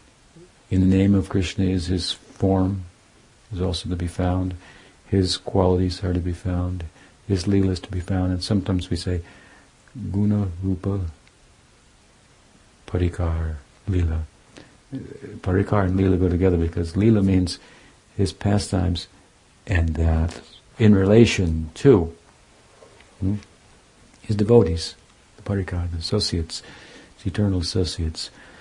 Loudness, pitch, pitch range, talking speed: -22 LUFS, 95 Hz, 85-100 Hz, 120 wpm